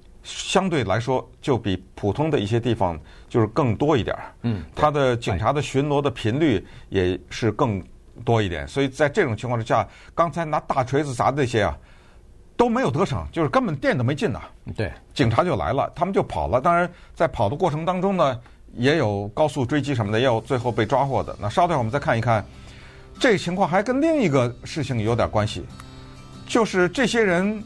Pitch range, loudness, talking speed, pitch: 105-155 Hz, -22 LUFS, 300 characters per minute, 125 Hz